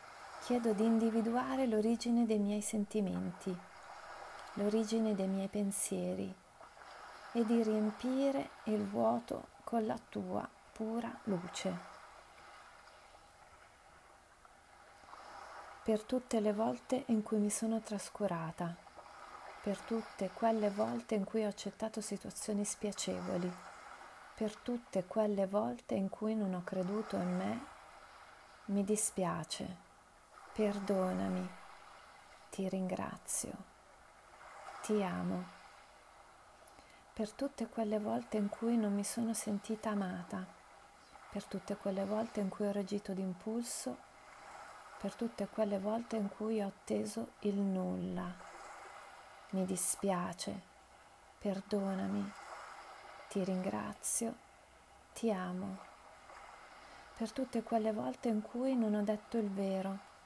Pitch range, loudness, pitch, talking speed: 195-225 Hz, -38 LUFS, 210 Hz, 105 wpm